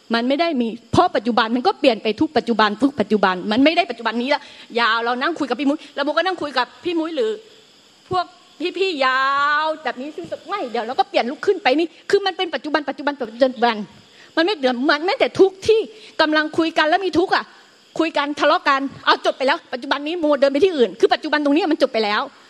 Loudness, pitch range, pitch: -19 LUFS, 255-345 Hz, 295 Hz